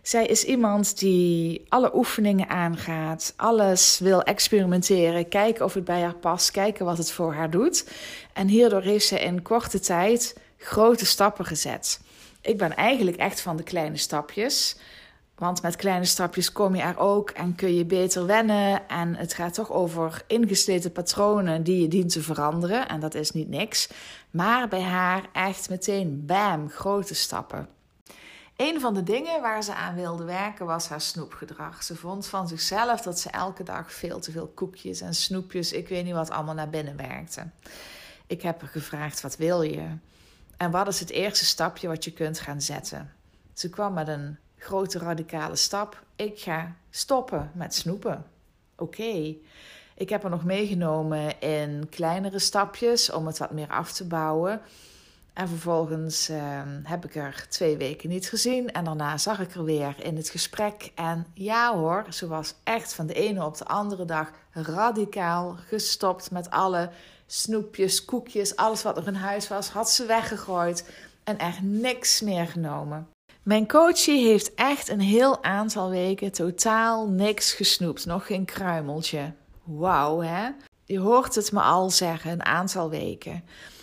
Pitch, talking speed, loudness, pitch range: 180 Hz, 170 wpm, -25 LUFS, 165-205 Hz